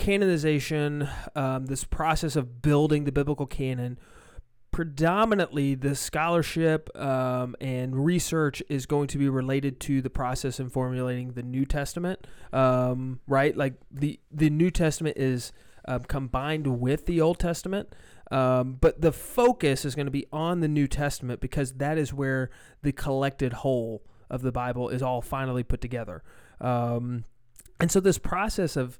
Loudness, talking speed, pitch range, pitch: -27 LUFS, 155 wpm, 130-155 Hz, 140 Hz